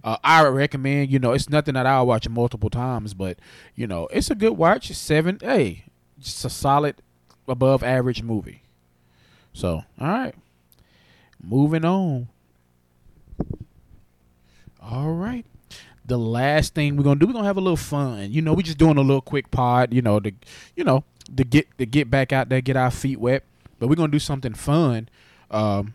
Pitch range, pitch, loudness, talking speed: 105-145 Hz, 130 Hz, -21 LUFS, 185 wpm